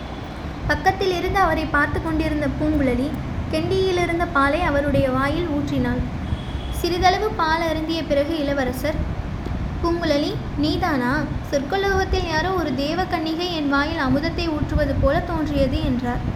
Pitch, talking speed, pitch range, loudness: 320 Hz, 110 wpm, 285-350 Hz, -22 LUFS